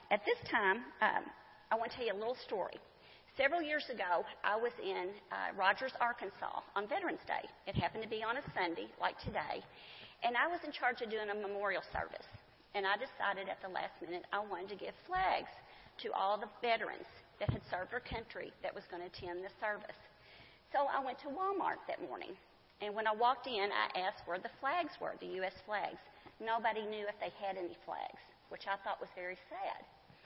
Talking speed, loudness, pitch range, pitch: 210 wpm, -39 LUFS, 200-265 Hz, 220 Hz